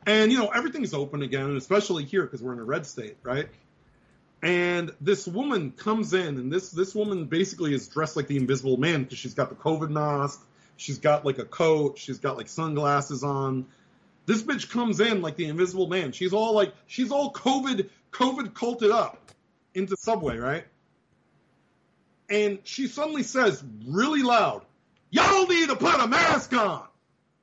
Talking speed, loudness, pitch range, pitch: 175 wpm, -26 LUFS, 145-215 Hz, 185 Hz